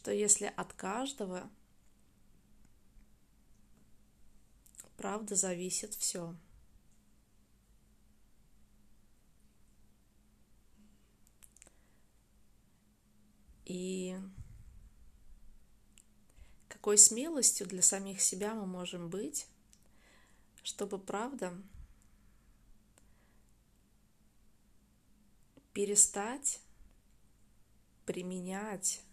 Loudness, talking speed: -32 LUFS, 40 wpm